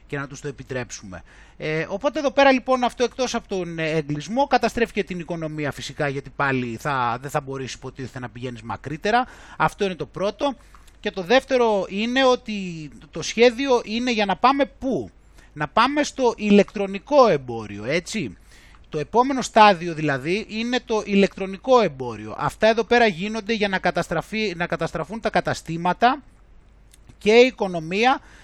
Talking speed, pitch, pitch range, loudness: 155 wpm, 195 Hz, 155-235 Hz, -22 LUFS